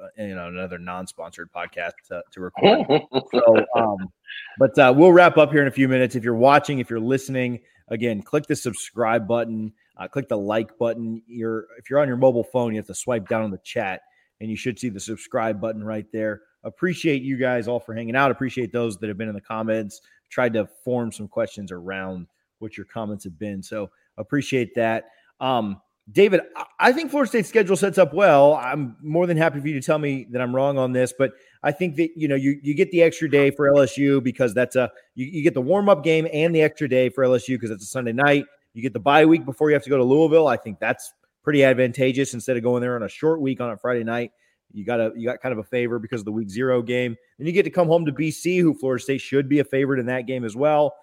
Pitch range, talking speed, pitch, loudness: 115-145 Hz, 250 wpm, 125 Hz, -21 LUFS